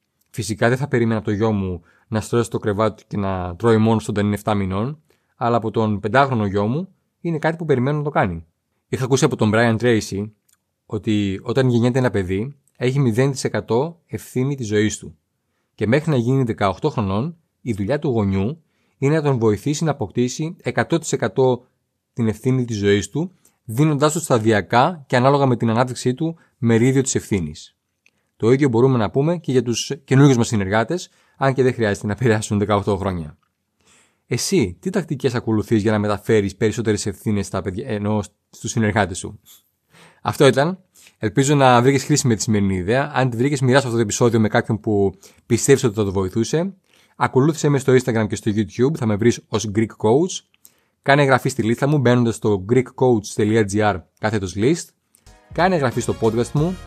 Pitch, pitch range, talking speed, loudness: 115 Hz, 105-135 Hz, 180 wpm, -19 LUFS